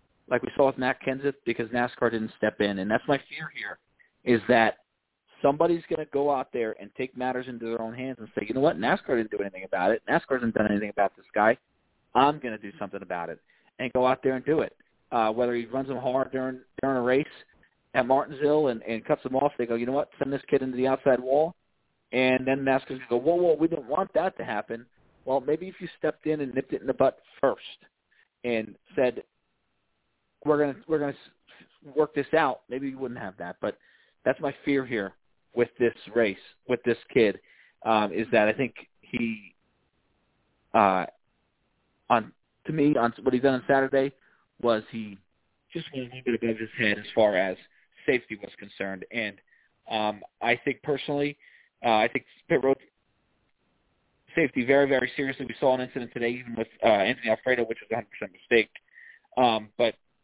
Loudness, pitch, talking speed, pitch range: -27 LUFS, 130 Hz, 205 wpm, 115-140 Hz